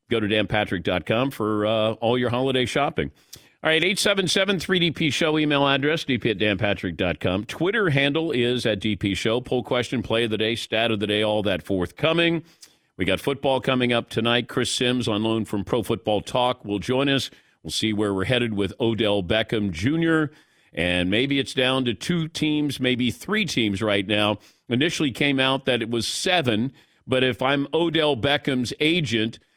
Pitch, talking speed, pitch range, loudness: 125 Hz, 180 wpm, 110-145 Hz, -23 LUFS